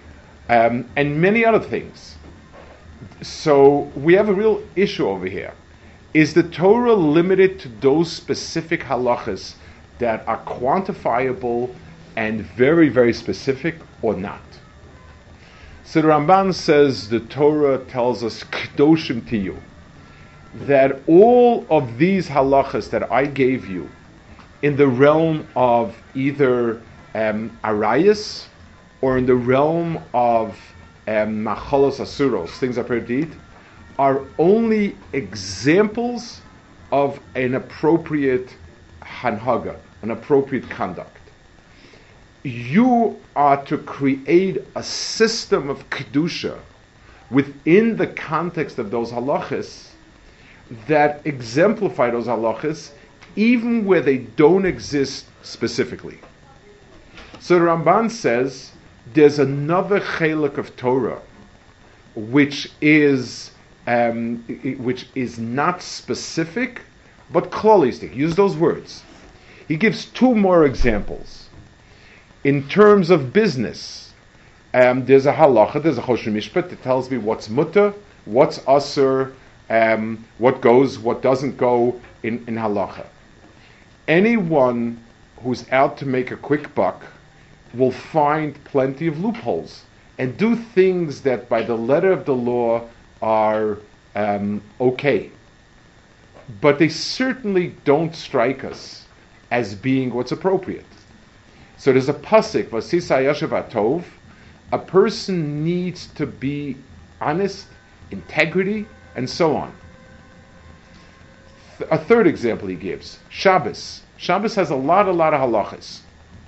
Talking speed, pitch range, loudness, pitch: 115 wpm, 115-160 Hz, -19 LUFS, 135 Hz